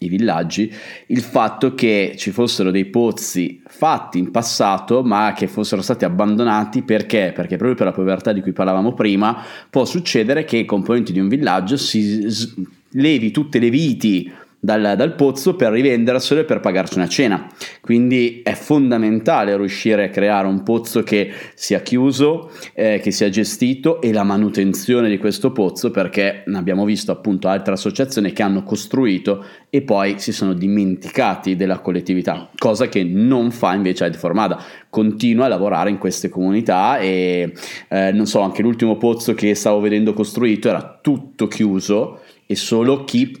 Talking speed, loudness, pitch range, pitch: 165 wpm, -17 LUFS, 100-120 Hz, 105 Hz